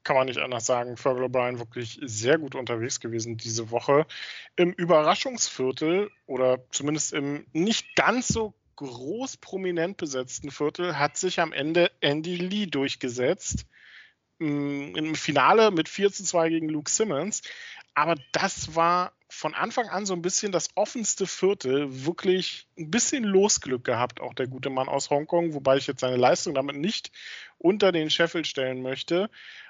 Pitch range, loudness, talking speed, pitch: 130-185 Hz, -26 LUFS, 155 wpm, 155 Hz